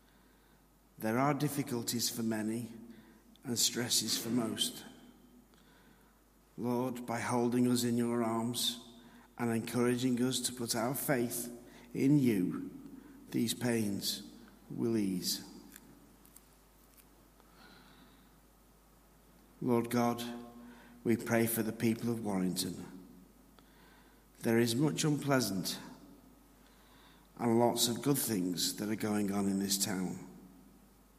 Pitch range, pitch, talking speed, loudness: 110-125 Hz, 120 Hz, 105 wpm, -33 LUFS